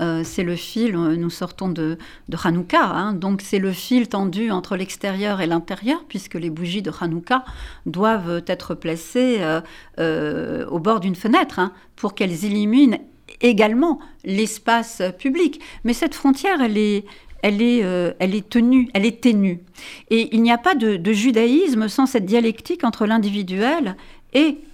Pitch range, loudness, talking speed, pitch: 180-240 Hz, -20 LUFS, 165 wpm, 210 Hz